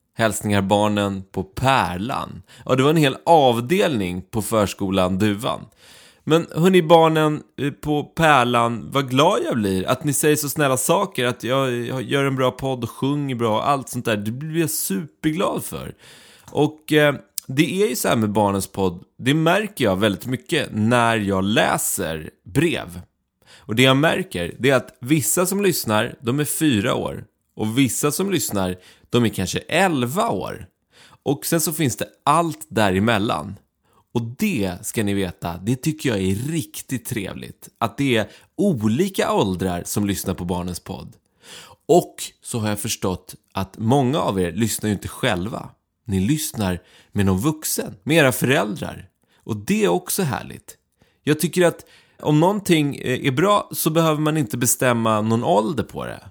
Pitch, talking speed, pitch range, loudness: 125 Hz, 170 wpm, 100-150 Hz, -20 LUFS